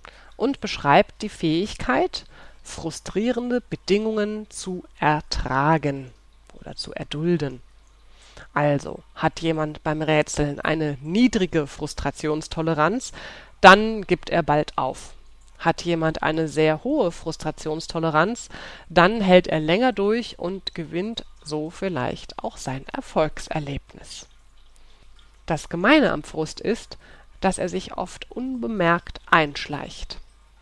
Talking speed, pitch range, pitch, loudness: 105 wpm, 150-195 Hz, 165 Hz, -23 LUFS